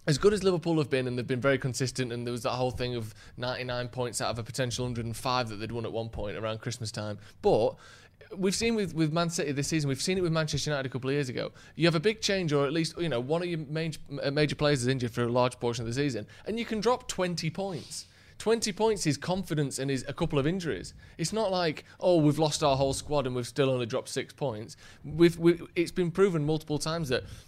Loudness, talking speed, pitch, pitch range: -29 LUFS, 260 wpm, 145 Hz, 125-170 Hz